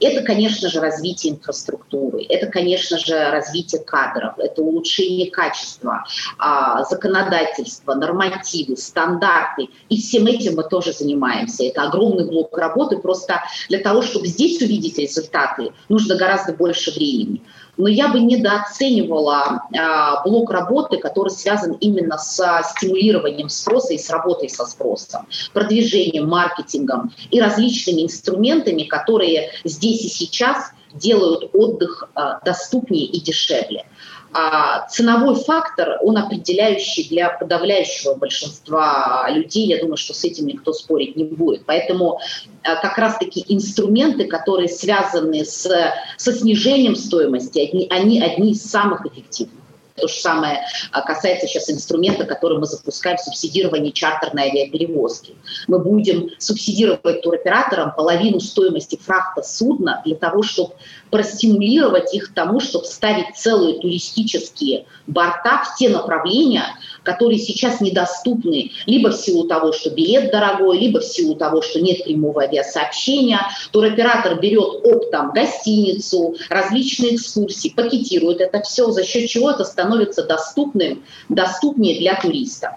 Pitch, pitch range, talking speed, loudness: 190 Hz, 165-230 Hz, 130 wpm, -18 LUFS